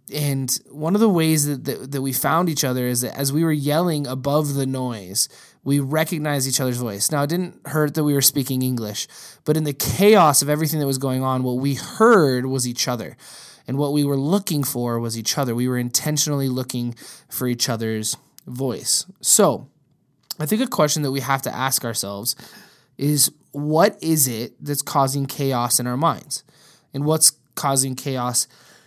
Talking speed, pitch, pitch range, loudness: 195 wpm, 140 Hz, 125-150 Hz, -20 LUFS